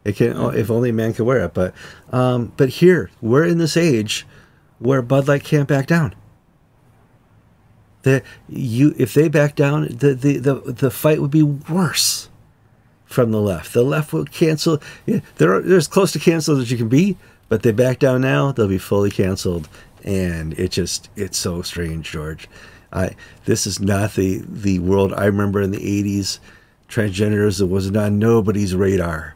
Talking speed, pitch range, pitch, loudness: 180 wpm, 100-140 Hz, 115 Hz, -18 LUFS